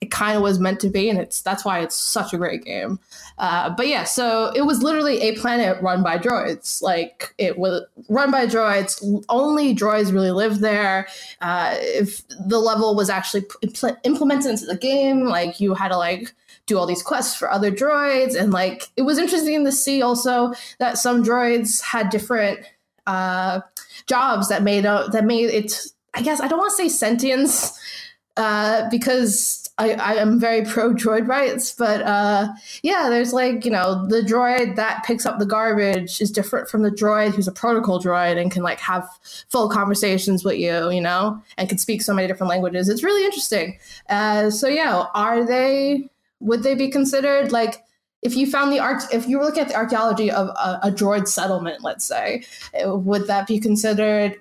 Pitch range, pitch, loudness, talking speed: 200-250 Hz, 220 Hz, -20 LUFS, 195 wpm